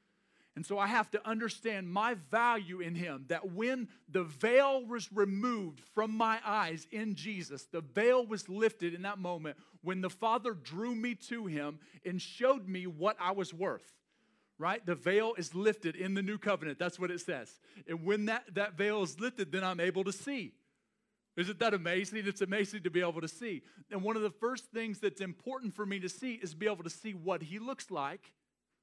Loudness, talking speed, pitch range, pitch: -35 LUFS, 205 wpm, 180-225 Hz, 200 Hz